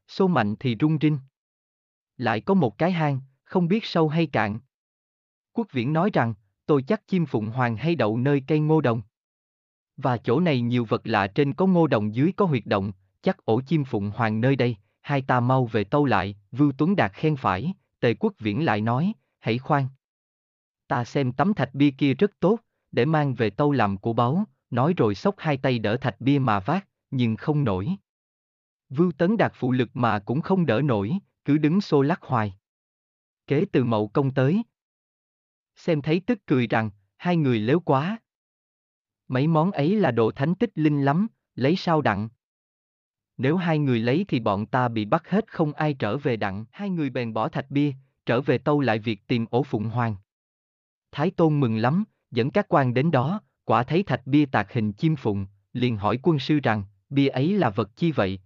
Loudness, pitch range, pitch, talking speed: -24 LUFS, 110-155 Hz, 130 Hz, 200 wpm